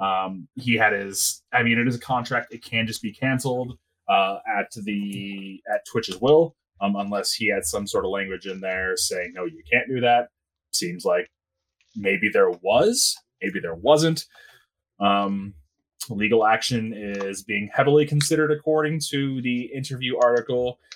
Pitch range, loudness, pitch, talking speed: 100-130 Hz, -23 LUFS, 120 Hz, 165 wpm